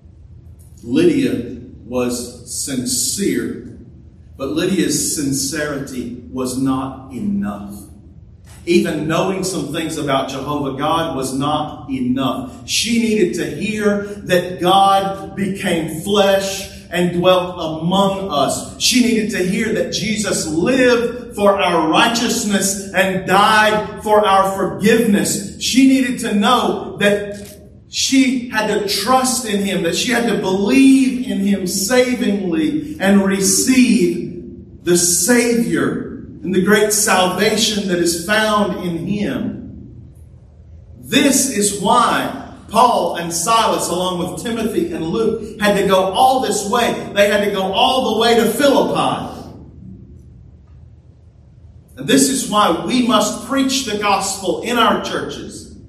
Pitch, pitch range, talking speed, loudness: 195 Hz, 170-225 Hz, 125 wpm, -16 LUFS